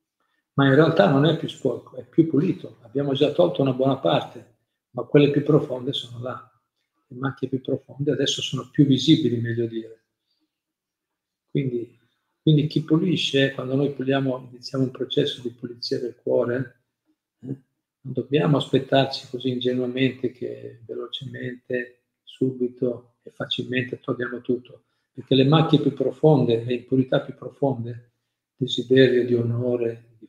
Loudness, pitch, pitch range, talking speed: -23 LUFS, 130 Hz, 125-140 Hz, 140 wpm